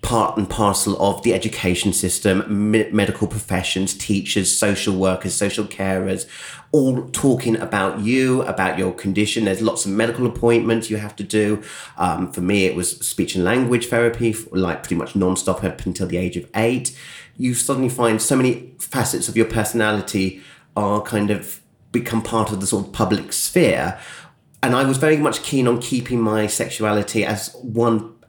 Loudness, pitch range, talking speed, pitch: -20 LUFS, 95-115 Hz, 180 wpm, 110 Hz